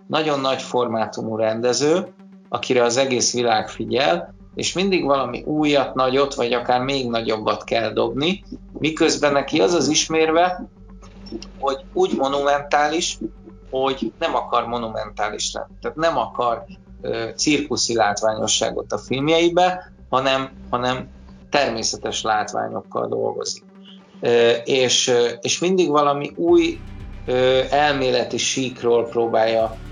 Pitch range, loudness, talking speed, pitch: 115-150 Hz, -20 LUFS, 115 wpm, 130 Hz